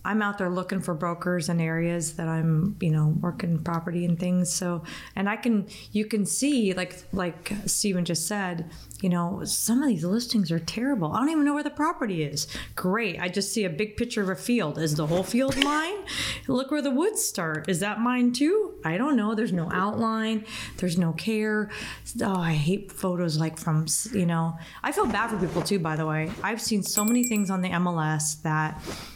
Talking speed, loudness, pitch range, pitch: 210 wpm, -26 LUFS, 170-220 Hz, 190 Hz